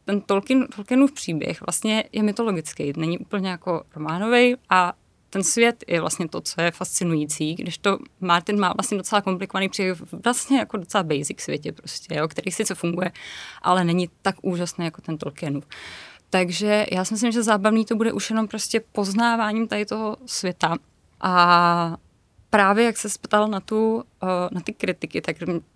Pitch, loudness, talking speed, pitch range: 195 Hz, -23 LUFS, 165 wpm, 175-220 Hz